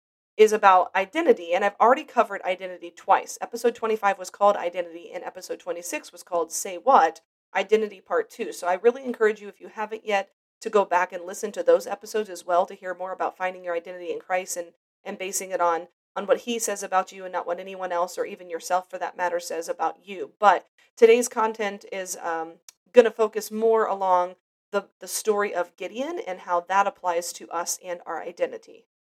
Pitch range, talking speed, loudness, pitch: 180-220 Hz, 210 wpm, -25 LUFS, 195 Hz